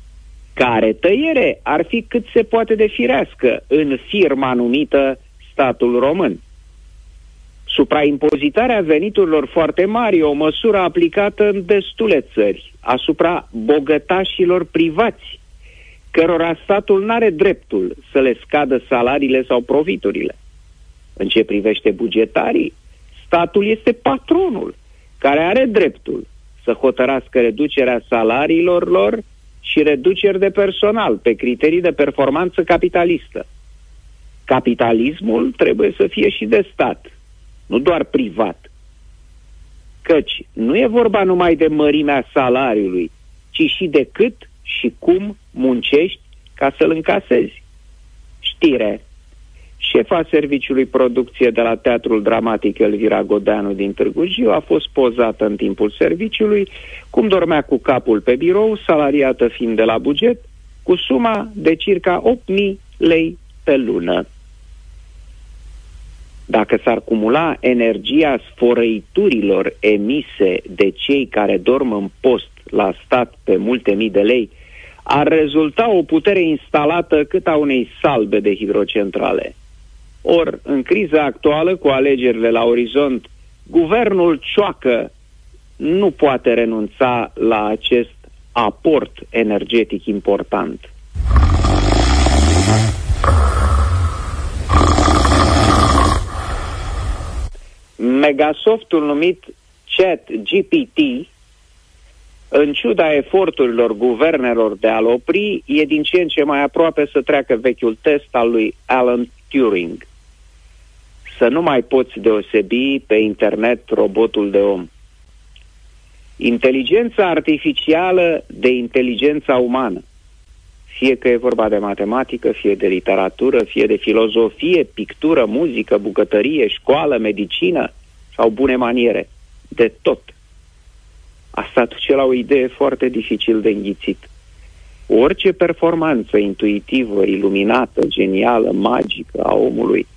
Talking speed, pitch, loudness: 110 wpm, 125 Hz, -16 LUFS